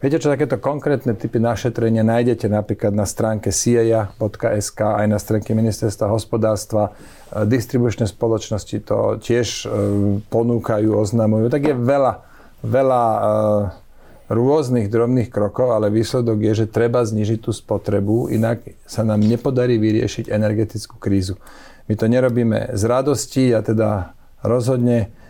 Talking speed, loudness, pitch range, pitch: 125 wpm, -19 LUFS, 105-120 Hz, 110 Hz